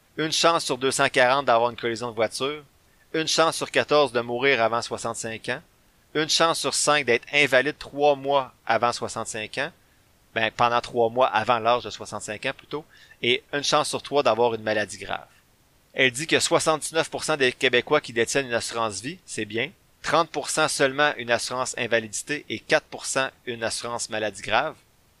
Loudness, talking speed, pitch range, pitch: -24 LUFS, 170 wpm, 115-145 Hz, 130 Hz